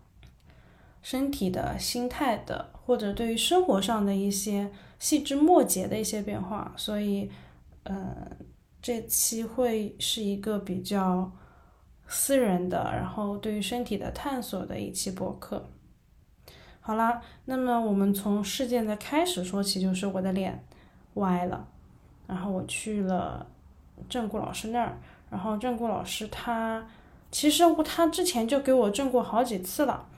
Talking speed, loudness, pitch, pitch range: 215 characters per minute, -28 LUFS, 220 Hz, 195-245 Hz